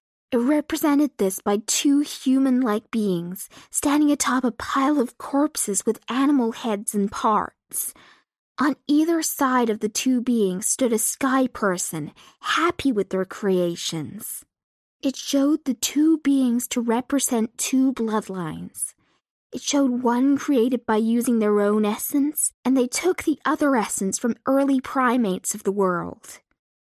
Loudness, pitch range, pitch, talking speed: -22 LUFS, 210-275 Hz, 245 Hz, 140 wpm